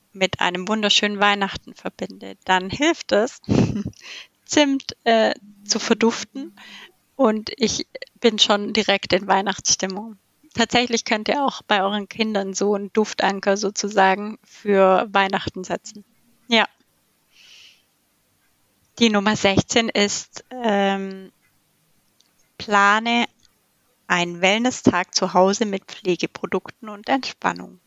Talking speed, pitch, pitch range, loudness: 105 wpm, 205 Hz, 195-230 Hz, -20 LUFS